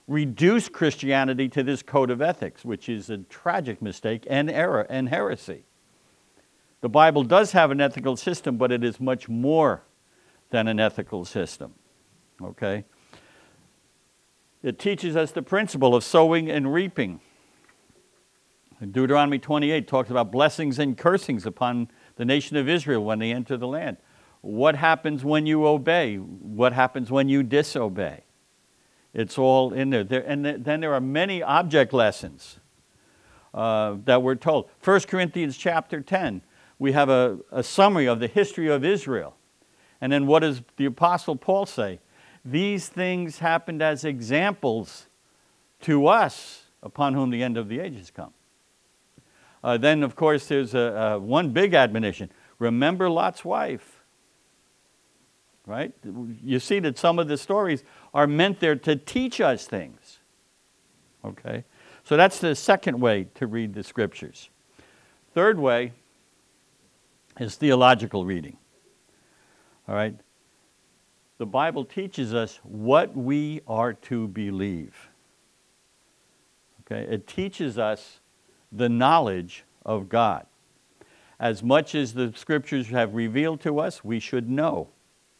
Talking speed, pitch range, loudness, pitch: 140 wpm, 115-155 Hz, -23 LUFS, 135 Hz